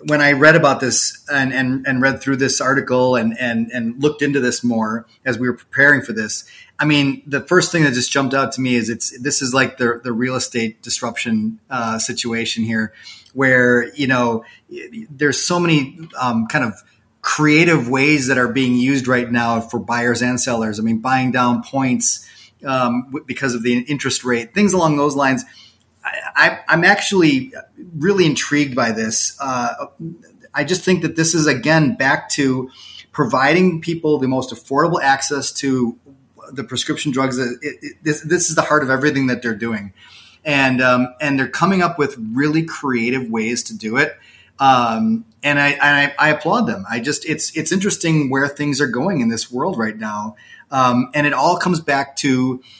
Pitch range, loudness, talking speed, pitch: 120-150 Hz, -16 LUFS, 190 wpm, 135 Hz